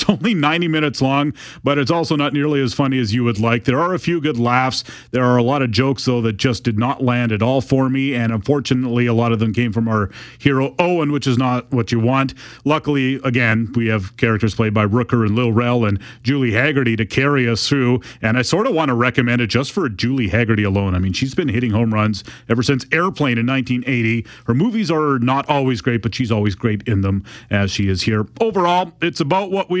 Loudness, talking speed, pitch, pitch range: -18 LUFS, 240 wpm, 125 Hz, 115-140 Hz